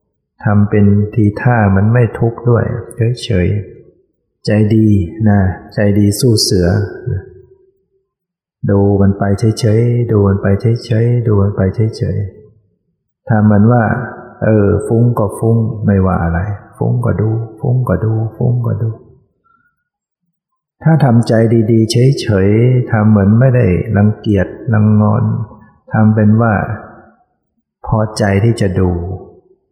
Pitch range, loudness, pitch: 105-120 Hz, -13 LUFS, 110 Hz